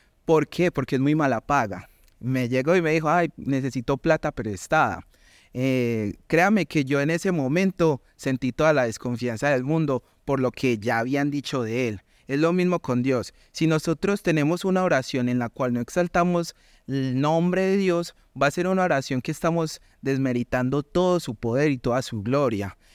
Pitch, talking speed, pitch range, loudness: 140 Hz, 185 wpm, 125-165 Hz, -24 LUFS